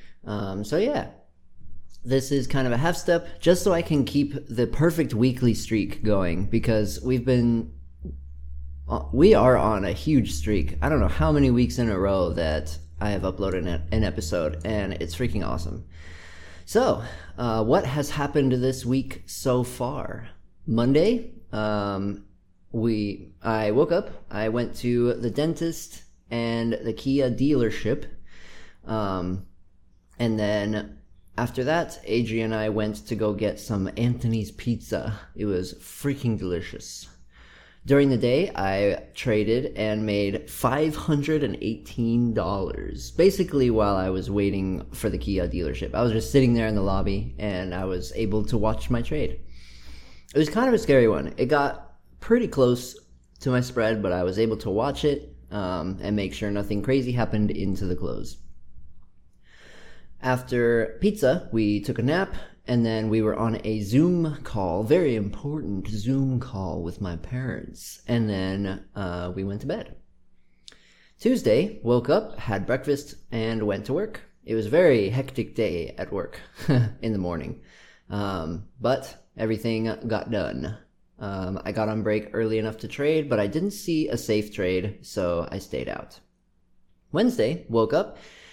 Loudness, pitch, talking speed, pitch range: -25 LUFS, 110 Hz, 160 wpm, 95-125 Hz